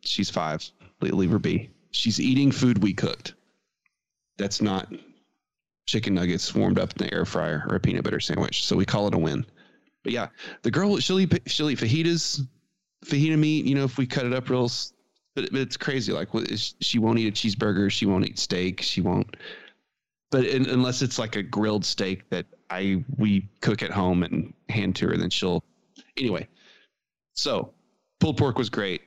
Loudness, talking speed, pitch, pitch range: -25 LUFS, 190 wpm, 115 Hz, 100-135 Hz